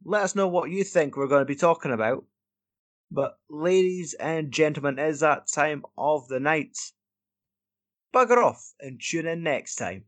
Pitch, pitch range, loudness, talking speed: 150 Hz, 130-170 Hz, -25 LUFS, 180 wpm